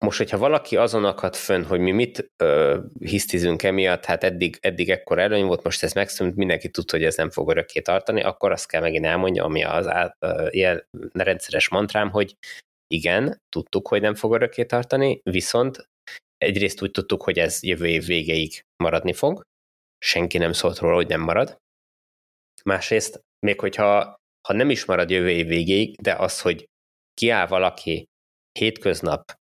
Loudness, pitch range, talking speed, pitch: -22 LUFS, 85-120 Hz, 170 wpm, 95 Hz